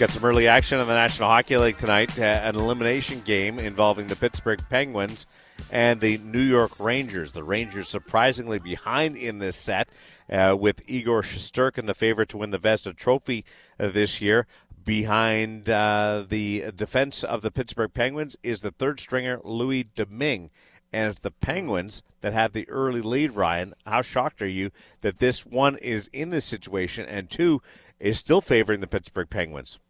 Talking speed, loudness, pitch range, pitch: 170 wpm, -24 LUFS, 105-120 Hz, 110 Hz